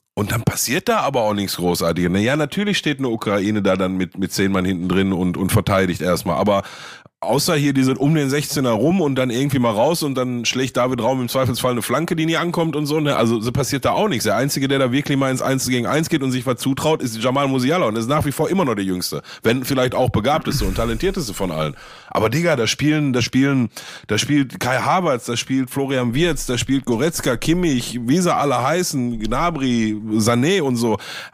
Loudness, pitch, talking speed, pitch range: -19 LUFS, 130 Hz, 230 wpm, 110-140 Hz